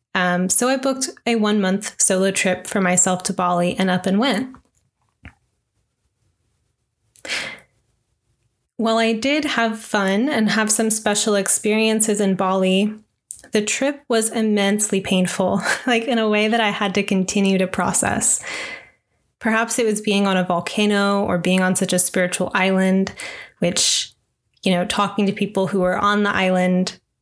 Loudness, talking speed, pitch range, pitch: -18 LUFS, 155 wpm, 185-220 Hz, 200 Hz